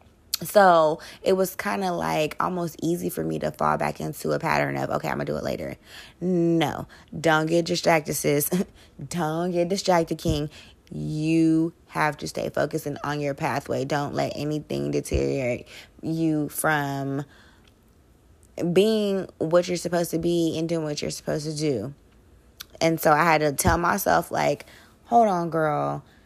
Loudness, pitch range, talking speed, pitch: -24 LUFS, 140-170 Hz, 160 wpm, 155 Hz